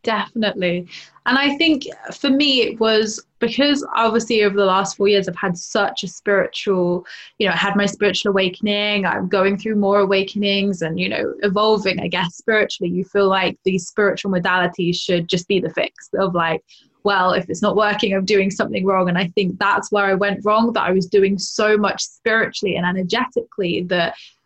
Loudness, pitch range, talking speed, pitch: -18 LUFS, 185-210 Hz, 195 wpm, 200 Hz